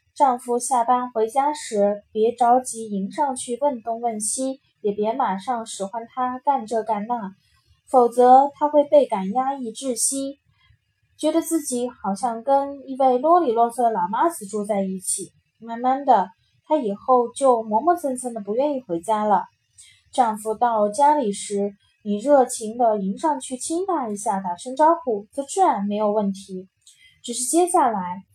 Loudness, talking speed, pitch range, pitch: -21 LUFS, 235 characters per minute, 210-275 Hz, 240 Hz